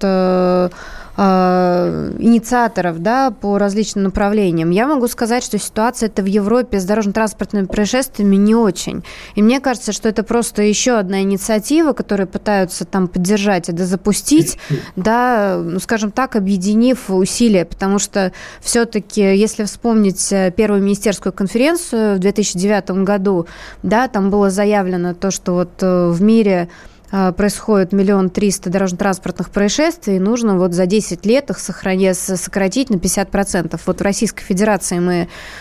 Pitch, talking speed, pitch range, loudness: 200 Hz, 135 wpm, 185-220 Hz, -16 LUFS